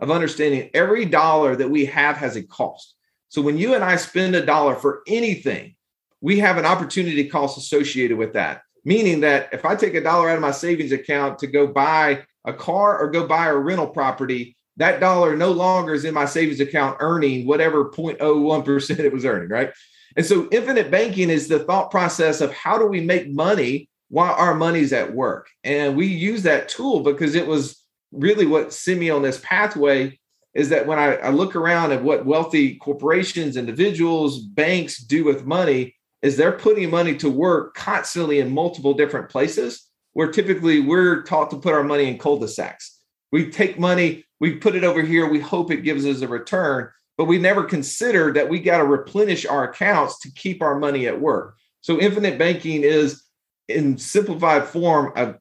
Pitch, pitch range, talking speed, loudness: 155 Hz, 140-175 Hz, 195 wpm, -19 LUFS